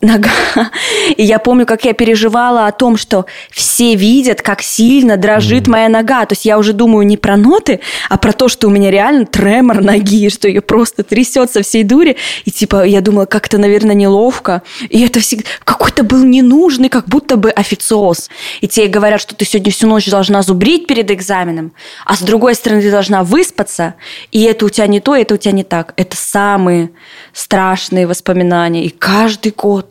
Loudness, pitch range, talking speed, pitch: -10 LUFS, 200-235 Hz, 190 wpm, 215 Hz